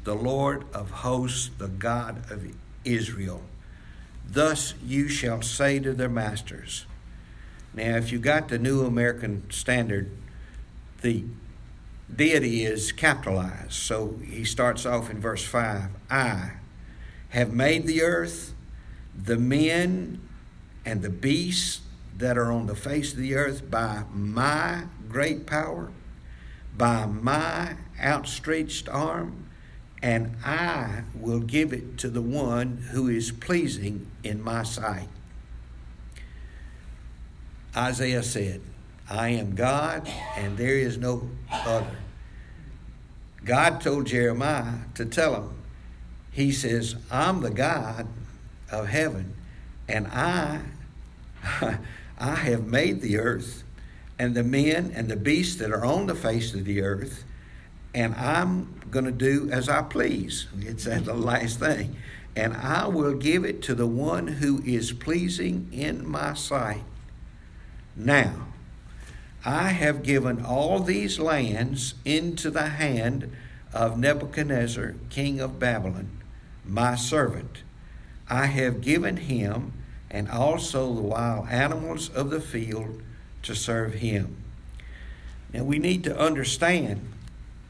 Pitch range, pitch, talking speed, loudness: 100-140 Hz, 120 Hz, 125 wpm, -27 LUFS